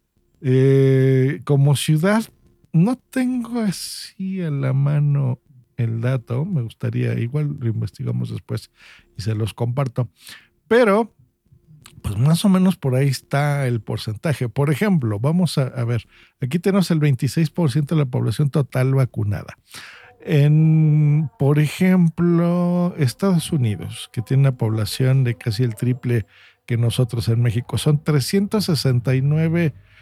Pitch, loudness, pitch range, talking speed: 135 Hz, -20 LUFS, 120-160 Hz, 130 wpm